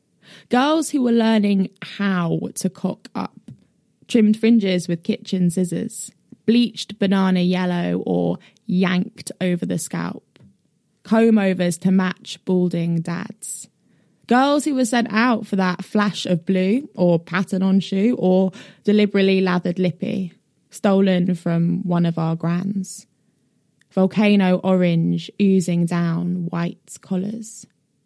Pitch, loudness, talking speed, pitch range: 190 Hz, -20 LUFS, 120 wpm, 180-210 Hz